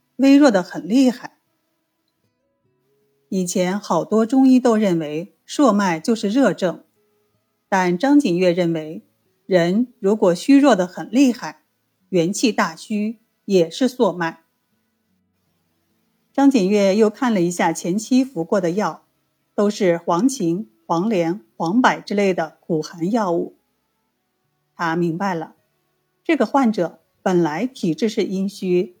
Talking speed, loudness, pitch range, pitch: 180 characters per minute, -19 LUFS, 170-225 Hz, 190 Hz